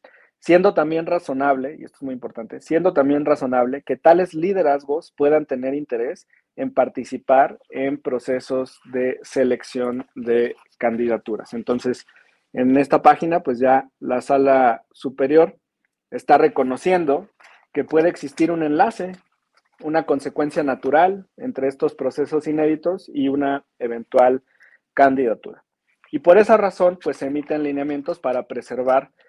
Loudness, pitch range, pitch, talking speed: -20 LUFS, 130-160 Hz, 140 Hz, 125 wpm